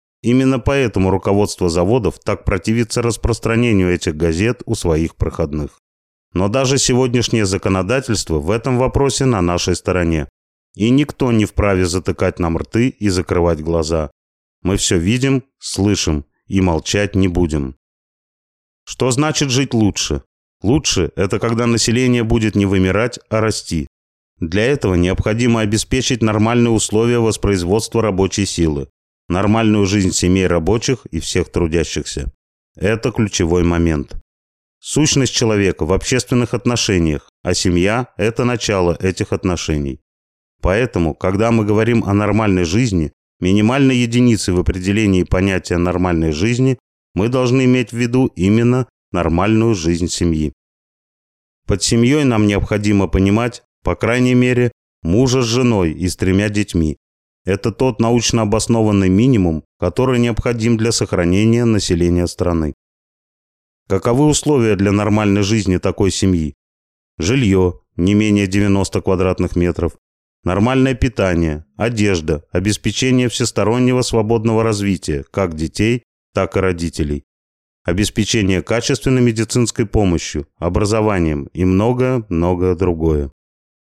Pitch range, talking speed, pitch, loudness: 85-115 Hz, 120 wpm, 100 Hz, -16 LUFS